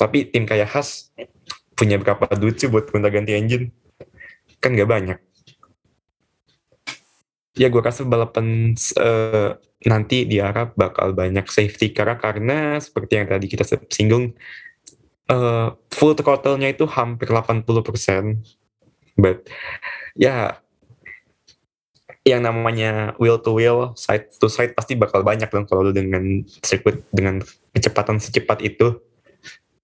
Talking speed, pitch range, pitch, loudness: 125 wpm, 105-120 Hz, 110 Hz, -19 LUFS